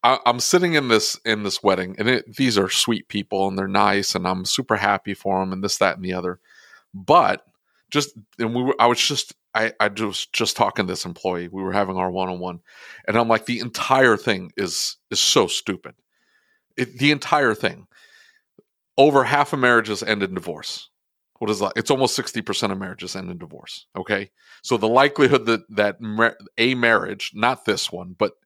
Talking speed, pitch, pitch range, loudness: 195 wpm, 110 Hz, 95-120 Hz, -21 LUFS